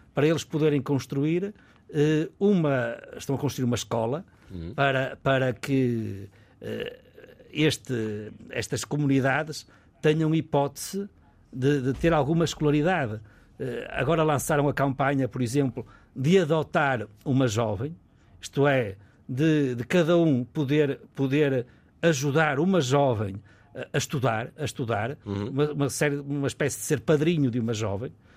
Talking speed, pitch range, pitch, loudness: 125 wpm, 120-150 Hz, 140 Hz, -26 LUFS